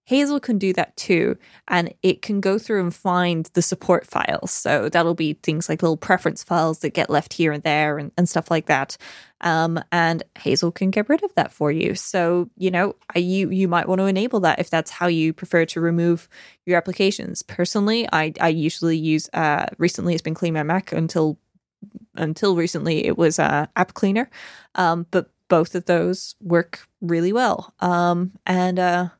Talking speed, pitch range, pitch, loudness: 195 wpm, 165-190 Hz, 175 Hz, -21 LUFS